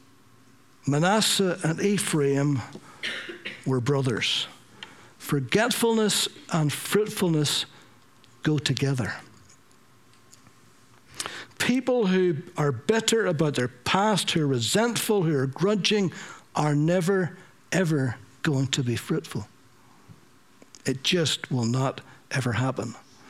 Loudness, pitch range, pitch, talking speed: -25 LUFS, 130-185 Hz, 145 Hz, 95 wpm